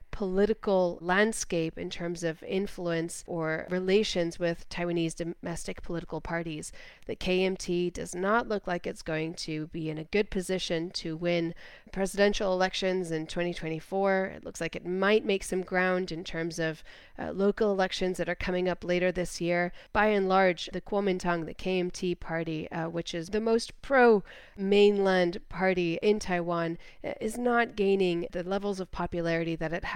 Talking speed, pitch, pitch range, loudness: 165 wpm, 180 Hz, 170-195 Hz, -29 LUFS